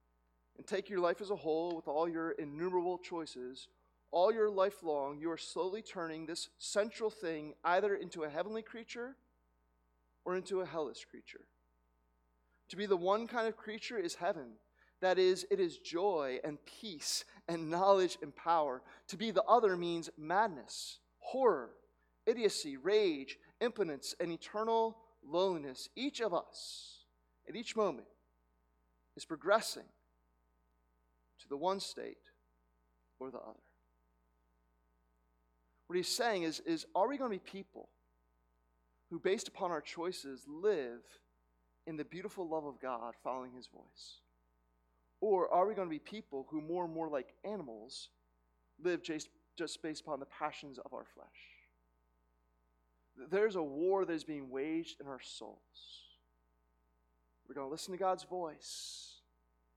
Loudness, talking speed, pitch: -37 LUFS, 150 wpm, 150 Hz